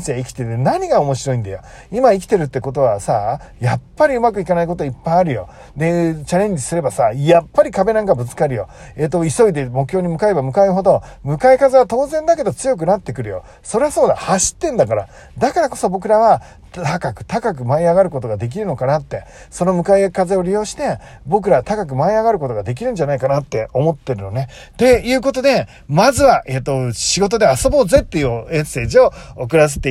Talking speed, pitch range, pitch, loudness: 445 characters per minute, 135-210 Hz, 170 Hz, -16 LUFS